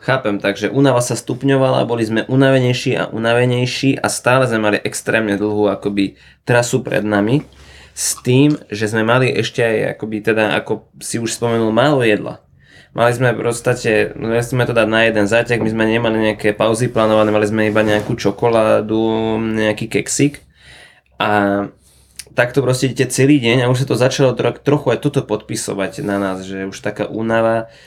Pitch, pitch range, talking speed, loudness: 115 Hz, 105-125 Hz, 170 wpm, -16 LUFS